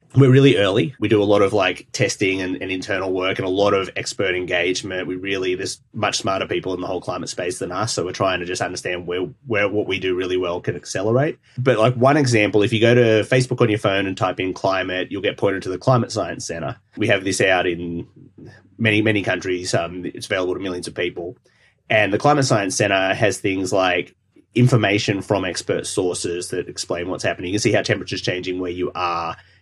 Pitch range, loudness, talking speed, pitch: 90-110 Hz, -20 LUFS, 225 wpm, 95 Hz